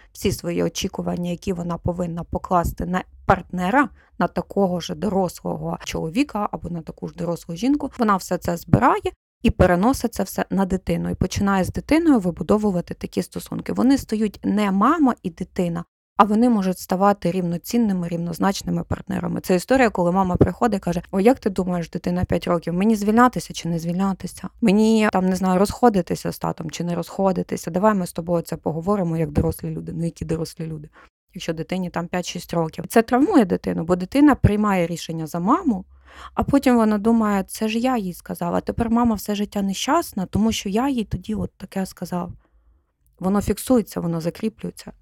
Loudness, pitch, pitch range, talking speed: -22 LUFS, 185 Hz, 170-215 Hz, 175 wpm